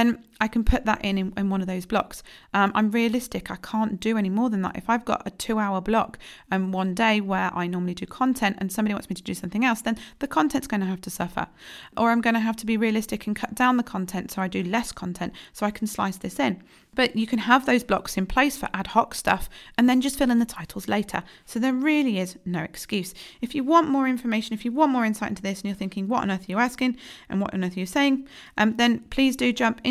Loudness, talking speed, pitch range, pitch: -25 LUFS, 275 wpm, 195-245 Hz, 220 Hz